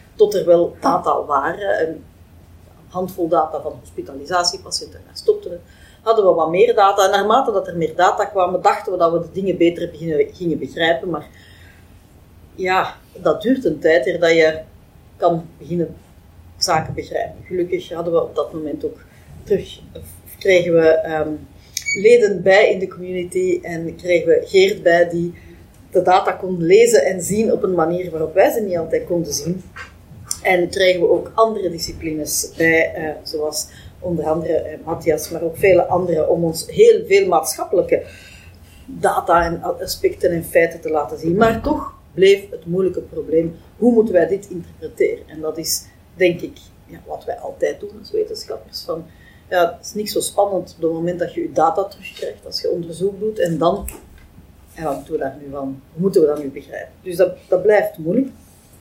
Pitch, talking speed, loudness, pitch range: 175 Hz, 180 wpm, -18 LUFS, 160-200 Hz